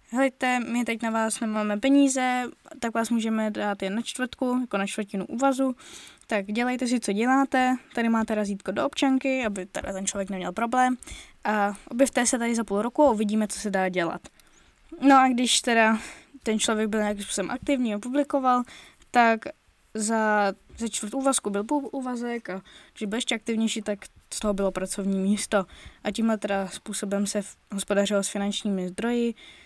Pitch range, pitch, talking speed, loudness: 205-250 Hz, 225 Hz, 175 wpm, -26 LUFS